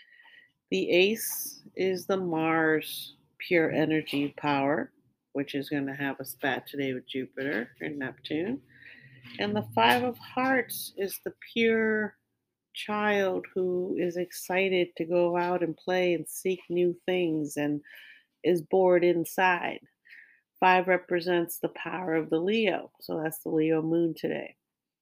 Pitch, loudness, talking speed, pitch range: 175 Hz, -28 LUFS, 140 wpm, 155-185 Hz